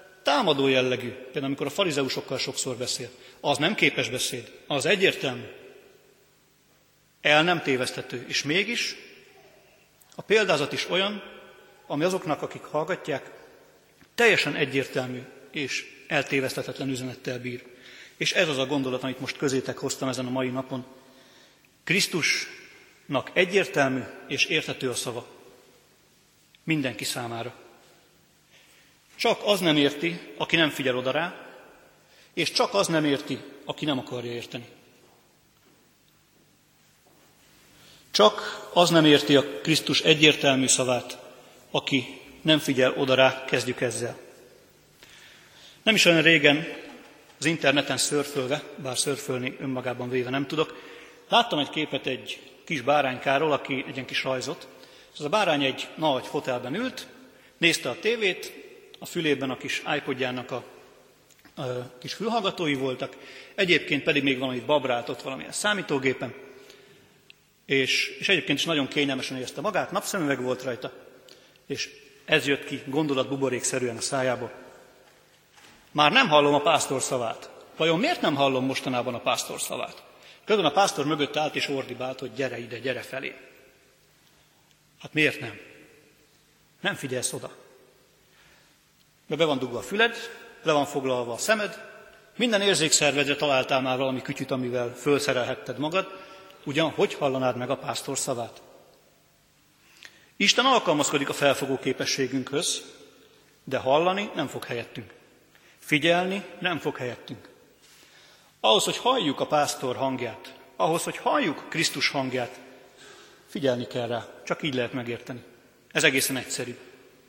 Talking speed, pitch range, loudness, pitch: 130 wpm, 130-160 Hz, -25 LUFS, 140 Hz